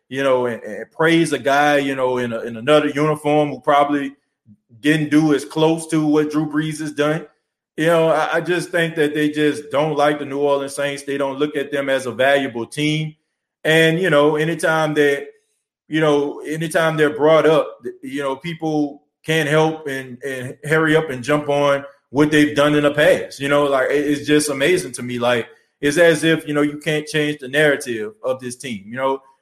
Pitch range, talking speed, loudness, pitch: 140-155 Hz, 210 wpm, -18 LUFS, 150 Hz